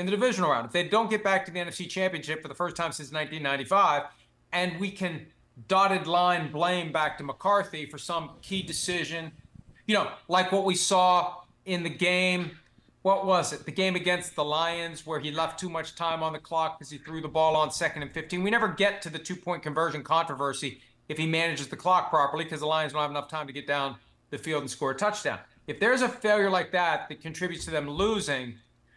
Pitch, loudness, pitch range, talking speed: 165 Hz, -28 LUFS, 155-185 Hz, 225 wpm